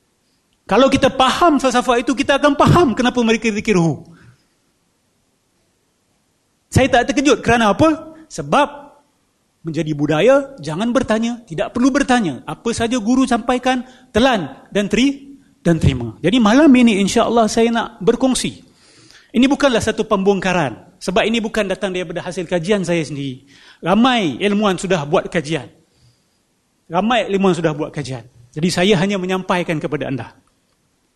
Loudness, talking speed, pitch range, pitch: -16 LUFS, 135 wpm, 170-255 Hz, 215 Hz